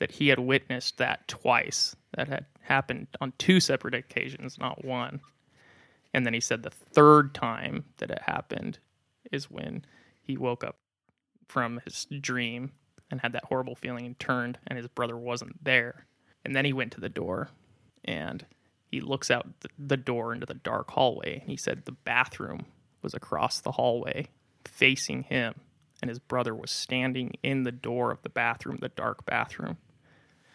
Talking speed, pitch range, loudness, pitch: 170 wpm, 120-135 Hz, -29 LUFS, 125 Hz